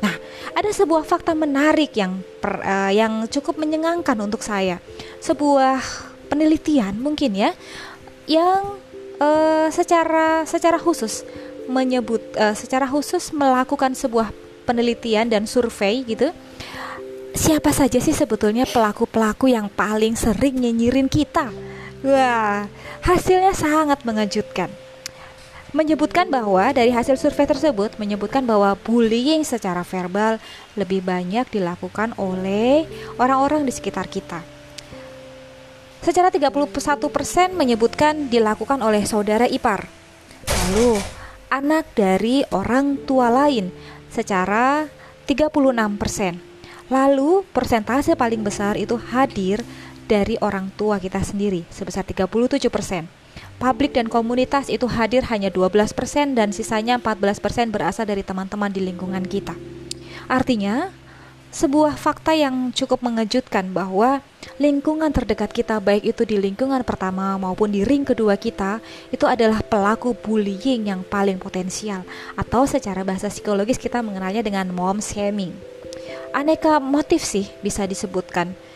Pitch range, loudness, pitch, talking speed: 200-280 Hz, -20 LUFS, 230 Hz, 115 wpm